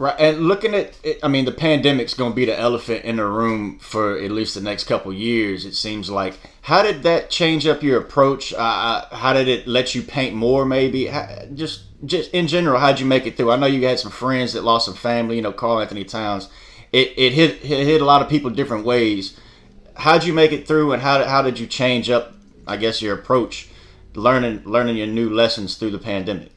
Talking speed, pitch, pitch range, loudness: 235 wpm, 120 Hz, 110-140 Hz, -19 LUFS